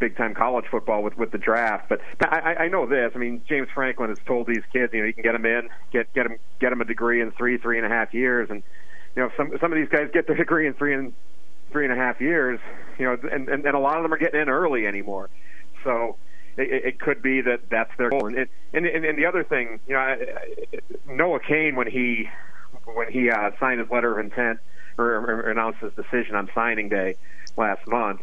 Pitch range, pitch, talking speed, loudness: 115-140 Hz, 125 Hz, 240 wpm, -24 LUFS